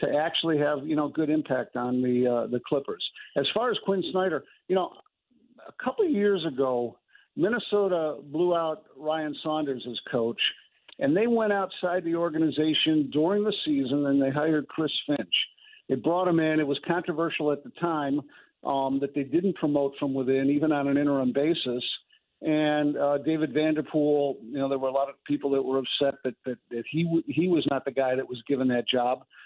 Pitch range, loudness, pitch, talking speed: 135-165 Hz, -27 LUFS, 150 Hz, 200 wpm